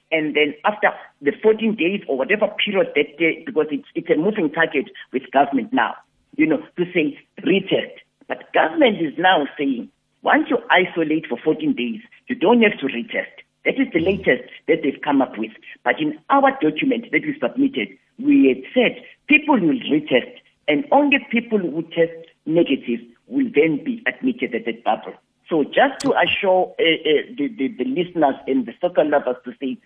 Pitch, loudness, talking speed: 180 Hz, -20 LUFS, 185 wpm